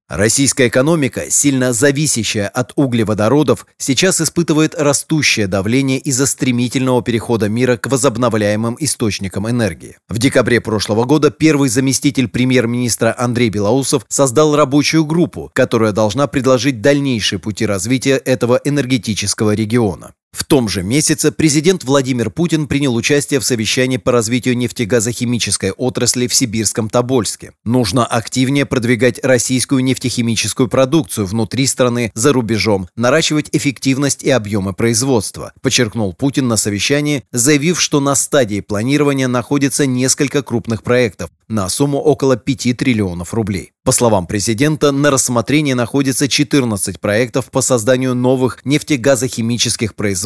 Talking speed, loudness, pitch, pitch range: 125 wpm, -14 LUFS, 125 Hz, 115-140 Hz